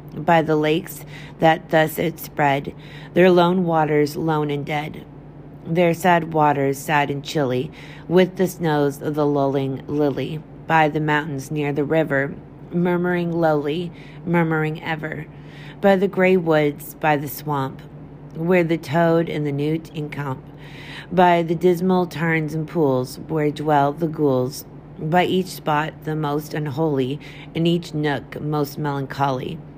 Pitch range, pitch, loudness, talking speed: 145-165 Hz, 150 Hz, -21 LUFS, 145 wpm